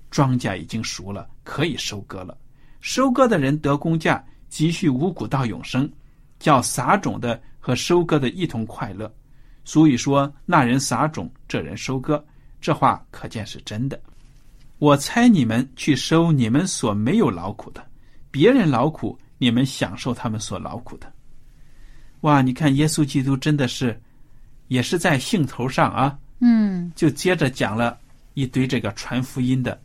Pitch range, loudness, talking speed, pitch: 125-150 Hz, -21 LUFS, 230 characters per minute, 135 Hz